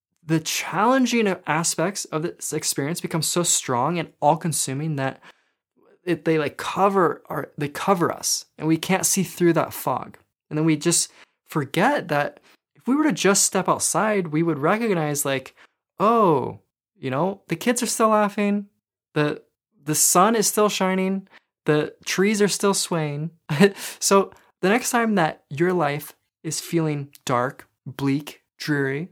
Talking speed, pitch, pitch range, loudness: 155 wpm, 165 Hz, 150-195 Hz, -22 LUFS